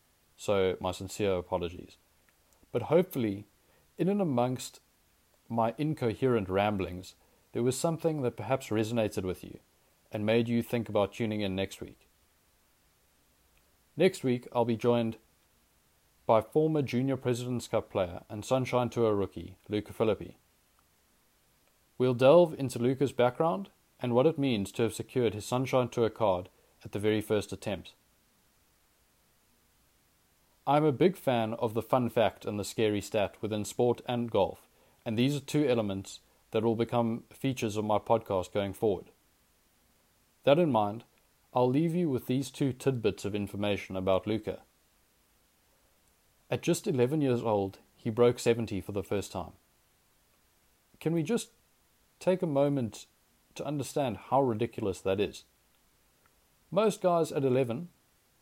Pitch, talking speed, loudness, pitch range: 115 Hz, 145 wpm, -30 LUFS, 95-130 Hz